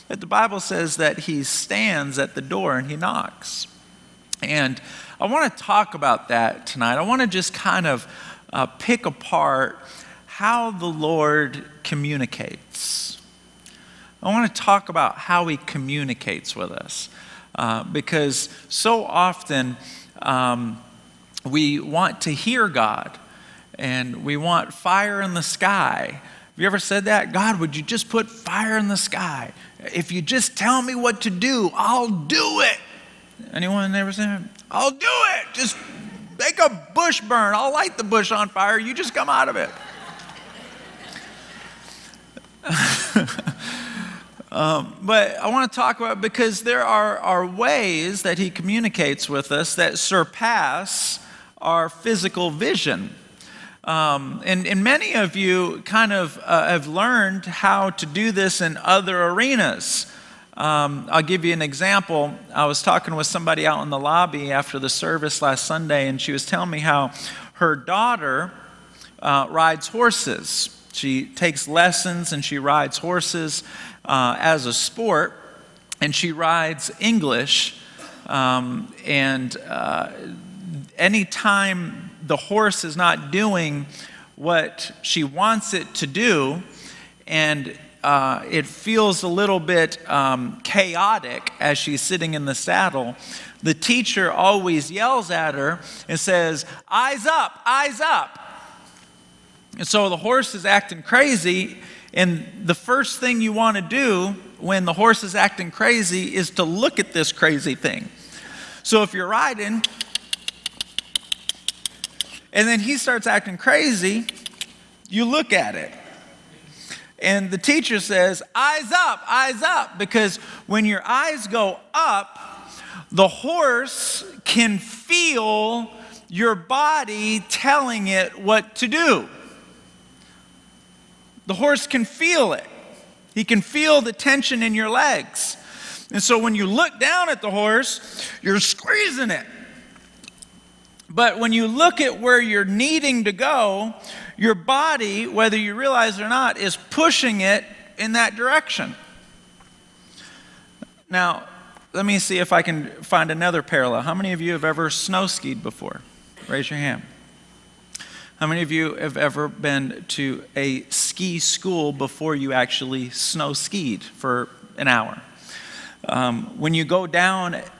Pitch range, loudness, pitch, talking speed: 160-225 Hz, -20 LUFS, 195 Hz, 140 wpm